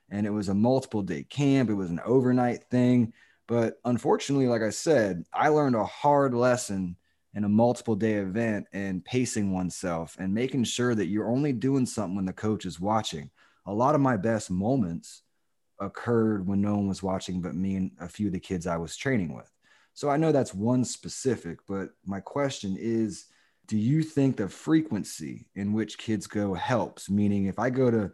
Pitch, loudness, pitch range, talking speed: 110 Hz, -27 LUFS, 95-125 Hz, 195 wpm